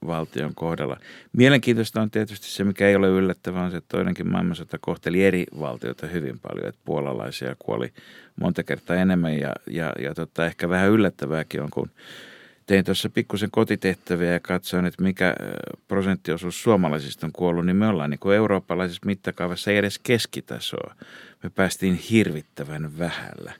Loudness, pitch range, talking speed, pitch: -24 LUFS, 85-100 Hz, 155 wpm, 90 Hz